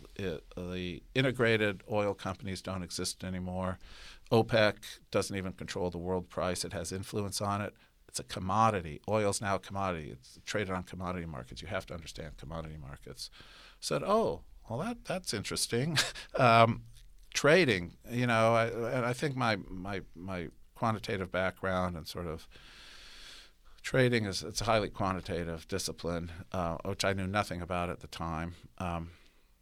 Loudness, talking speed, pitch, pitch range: -33 LUFS, 160 wpm, 95 Hz, 85-105 Hz